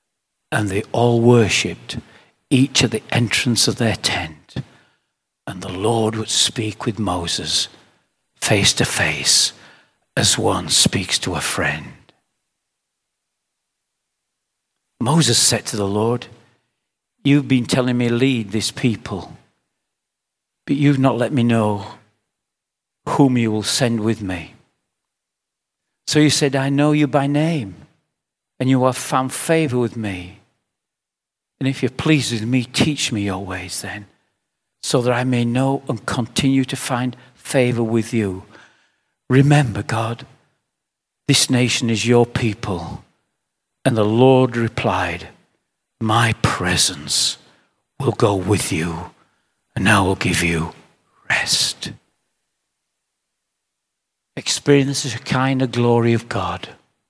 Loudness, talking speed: -18 LUFS, 125 wpm